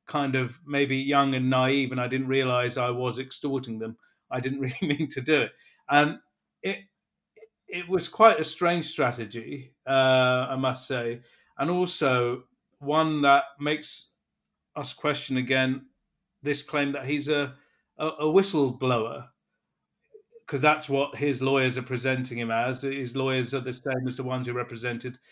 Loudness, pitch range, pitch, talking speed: -26 LUFS, 130-150 Hz, 135 Hz, 160 wpm